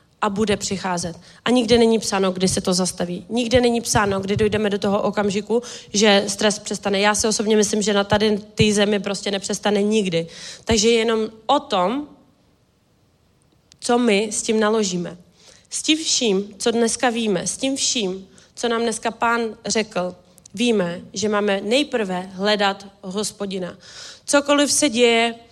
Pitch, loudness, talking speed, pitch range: 210 Hz, -20 LUFS, 155 wpm, 200-230 Hz